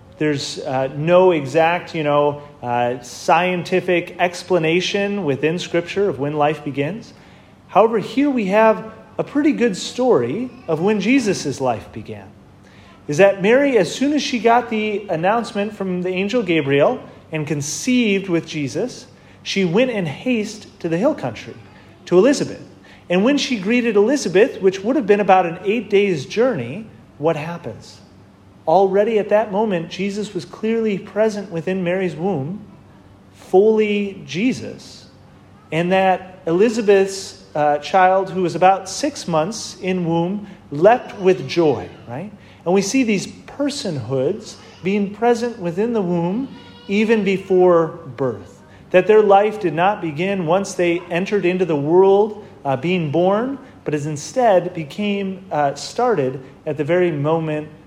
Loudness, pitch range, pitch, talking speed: -18 LUFS, 155-210 Hz, 185 Hz, 145 wpm